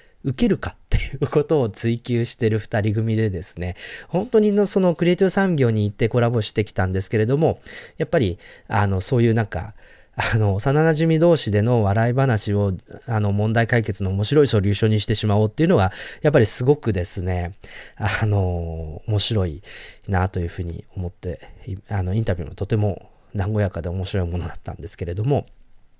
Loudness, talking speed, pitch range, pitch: -21 LUFS, 390 characters per minute, 95-120 Hz, 110 Hz